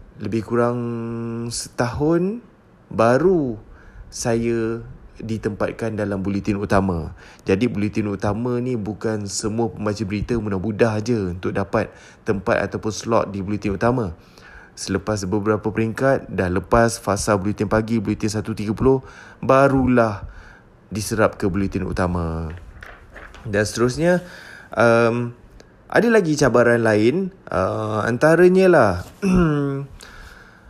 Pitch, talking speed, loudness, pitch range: 110 Hz, 100 wpm, -20 LUFS, 100-120 Hz